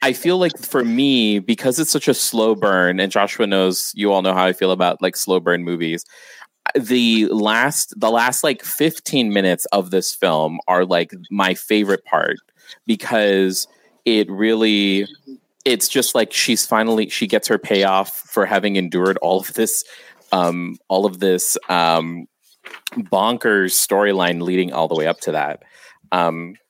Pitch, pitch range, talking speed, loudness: 95 Hz, 90-110 Hz, 165 wpm, -18 LUFS